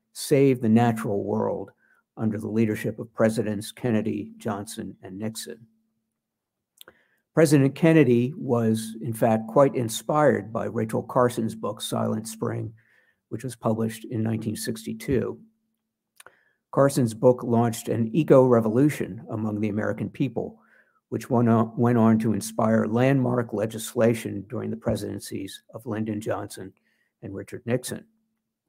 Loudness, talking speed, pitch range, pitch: -24 LUFS, 125 wpm, 110-125 Hz, 115 Hz